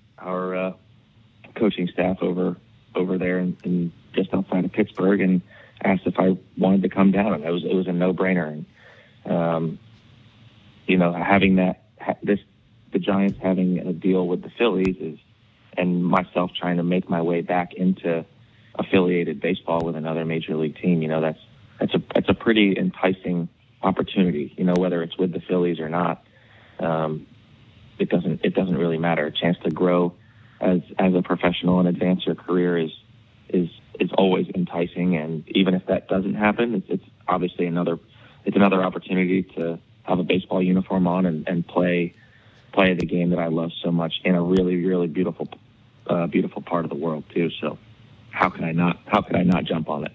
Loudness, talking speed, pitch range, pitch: -23 LUFS, 190 wpm, 85-95 Hz, 90 Hz